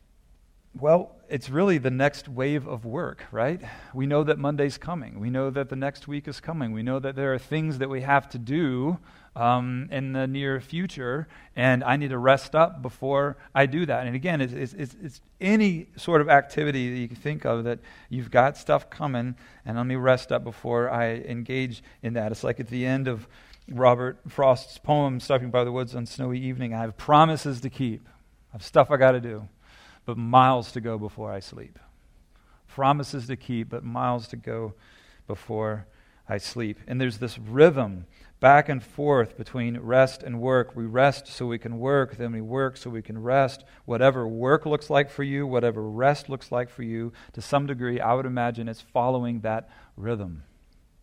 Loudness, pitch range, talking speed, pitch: -25 LUFS, 115-140 Hz, 200 wpm, 125 Hz